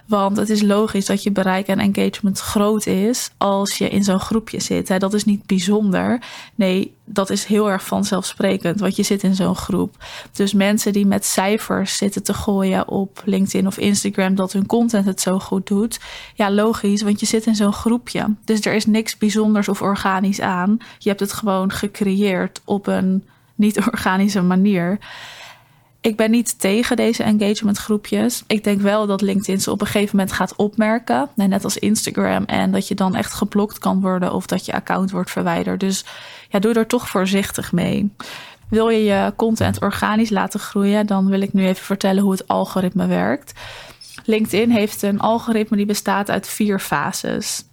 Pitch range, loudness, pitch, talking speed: 195-215 Hz, -19 LUFS, 205 Hz, 185 wpm